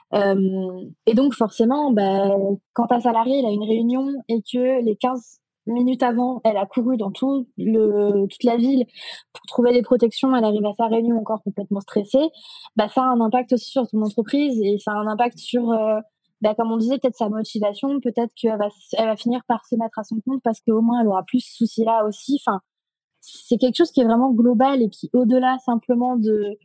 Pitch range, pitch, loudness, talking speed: 215-250 Hz, 230 Hz, -21 LUFS, 205 wpm